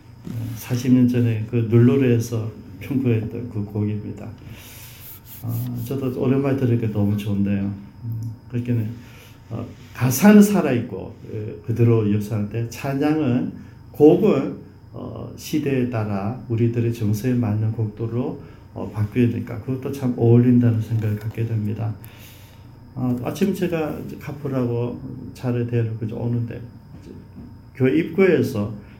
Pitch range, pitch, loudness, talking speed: 110-125 Hz, 115 Hz, -21 LUFS, 245 characters per minute